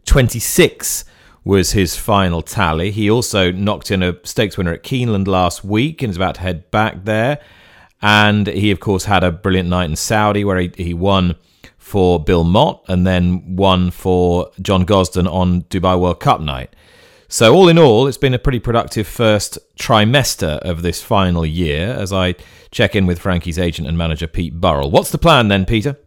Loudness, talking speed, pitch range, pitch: -15 LUFS, 185 wpm, 90-105 Hz, 95 Hz